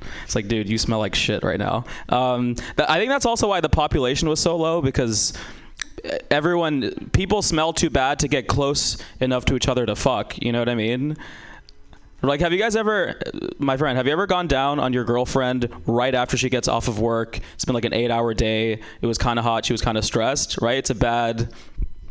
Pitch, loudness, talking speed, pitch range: 125 Hz, -21 LUFS, 230 wpm, 115-145 Hz